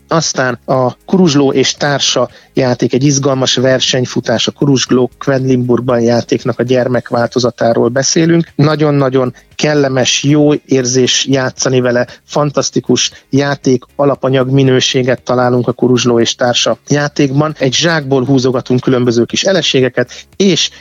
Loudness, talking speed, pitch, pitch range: -12 LUFS, 110 wpm, 130 Hz, 125-140 Hz